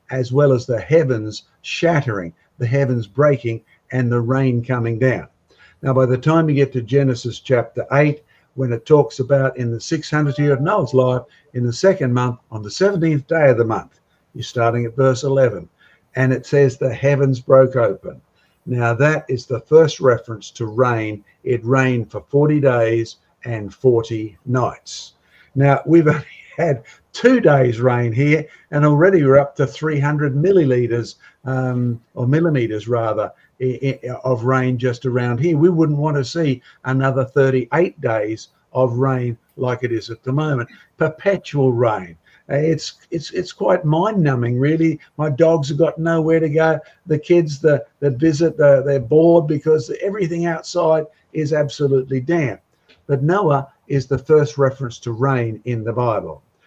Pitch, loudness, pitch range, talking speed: 135 Hz, -18 LUFS, 125-155 Hz, 165 wpm